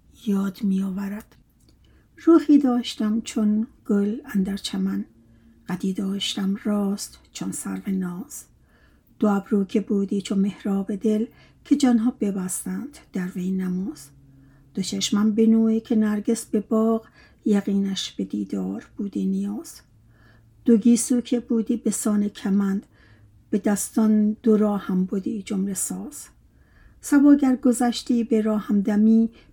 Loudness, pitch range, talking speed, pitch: -23 LUFS, 195-225 Hz, 125 wpm, 210 Hz